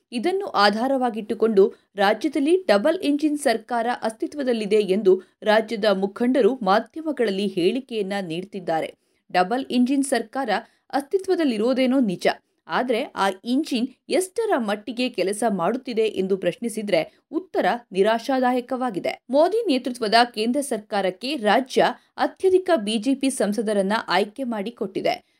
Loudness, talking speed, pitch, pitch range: -22 LUFS, 90 wpm, 235 Hz, 205-270 Hz